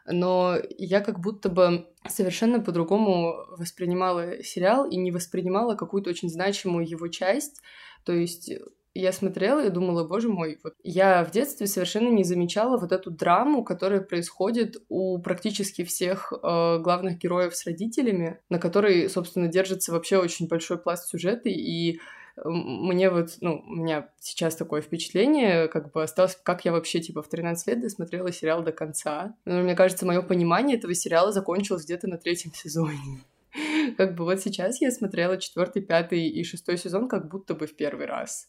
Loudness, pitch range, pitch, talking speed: -26 LUFS, 170-195 Hz, 180 Hz, 165 wpm